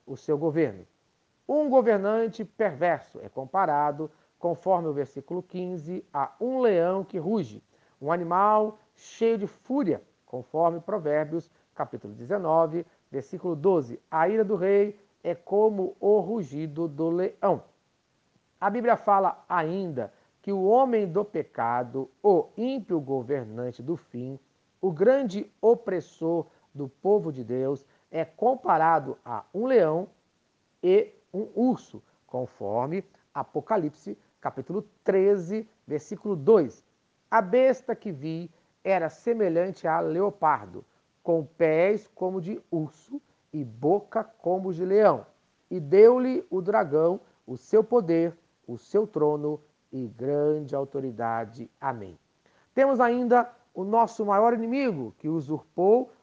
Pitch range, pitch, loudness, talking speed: 150-210 Hz, 180 Hz, -26 LUFS, 120 wpm